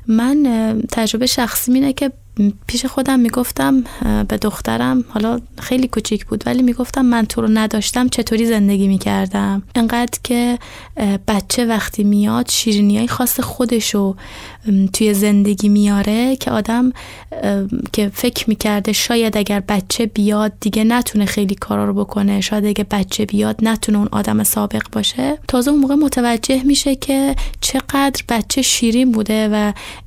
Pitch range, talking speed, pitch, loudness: 205-250 Hz, 140 wpm, 225 Hz, -16 LUFS